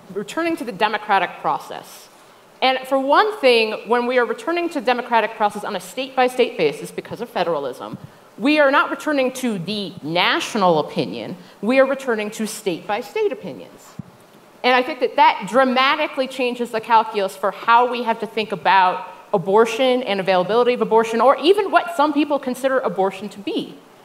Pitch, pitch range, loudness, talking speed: 240 Hz, 210-275 Hz, -19 LUFS, 180 wpm